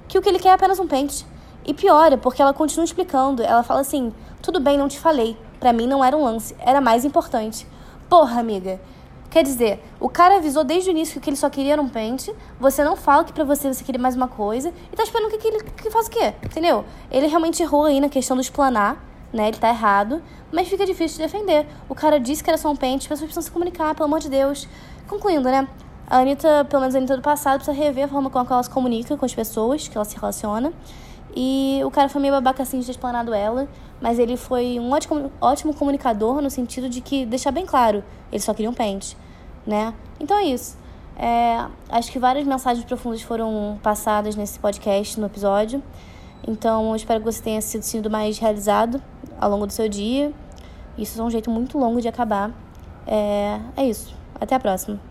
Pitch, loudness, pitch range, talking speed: 260 Hz, -21 LUFS, 225-300 Hz, 225 wpm